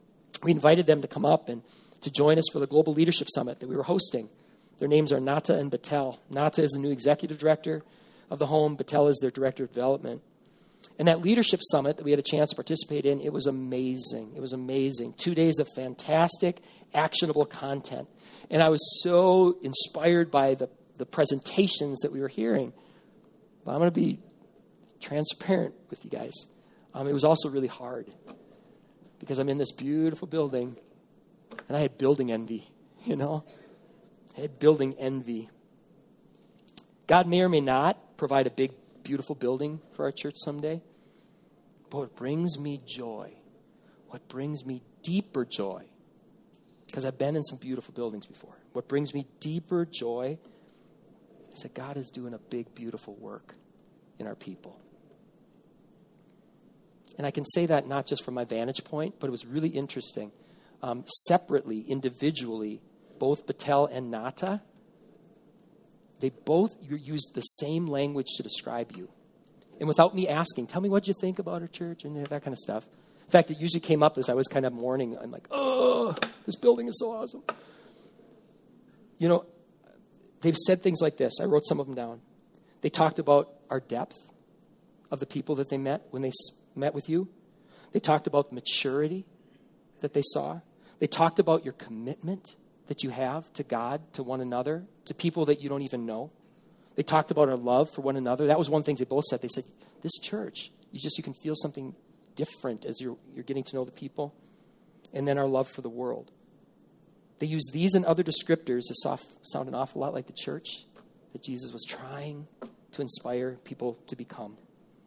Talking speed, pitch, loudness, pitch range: 180 wpm, 145 Hz, -28 LUFS, 130-165 Hz